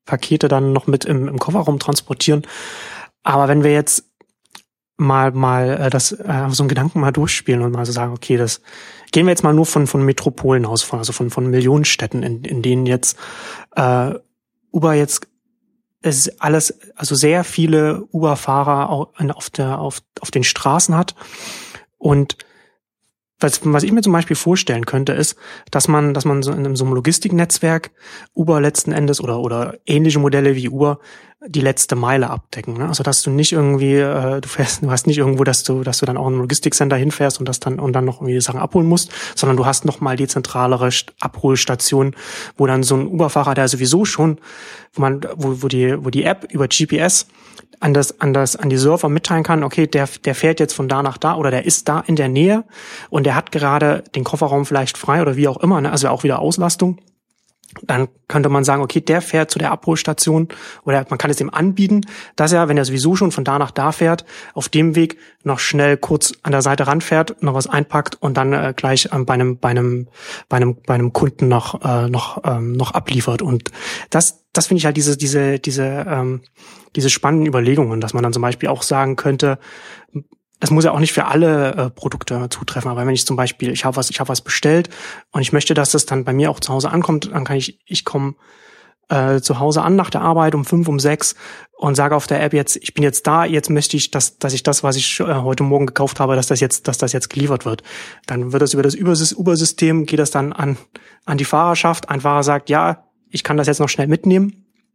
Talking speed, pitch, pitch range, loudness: 215 wpm, 145 Hz, 135-160 Hz, -16 LUFS